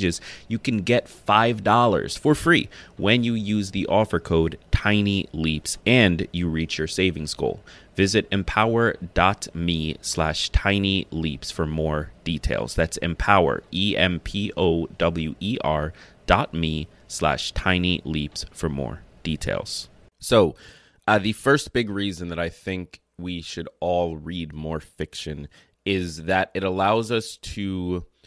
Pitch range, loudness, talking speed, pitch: 80-100 Hz, -23 LUFS, 125 wpm, 90 Hz